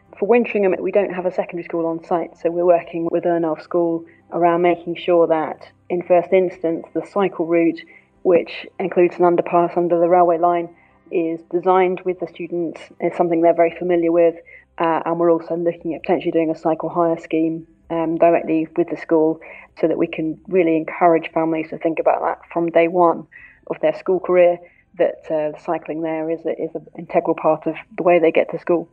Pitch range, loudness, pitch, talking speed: 165-175 Hz, -19 LUFS, 170 Hz, 200 wpm